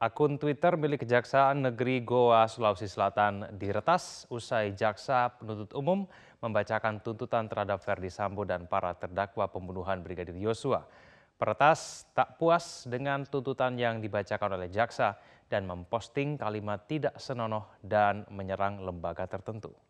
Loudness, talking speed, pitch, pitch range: -31 LUFS, 125 wpm, 110 Hz, 100-130 Hz